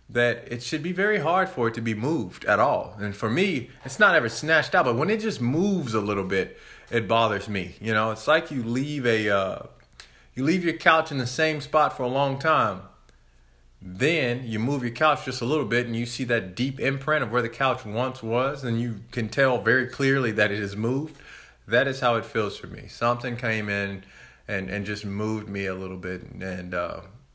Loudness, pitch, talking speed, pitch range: -25 LUFS, 120 Hz, 230 wpm, 105-135 Hz